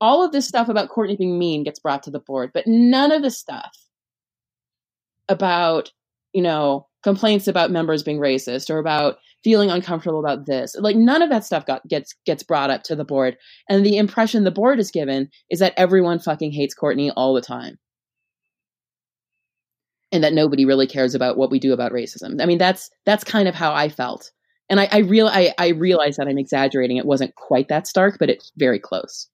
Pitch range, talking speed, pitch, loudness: 135-200 Hz, 205 wpm, 160 Hz, -19 LUFS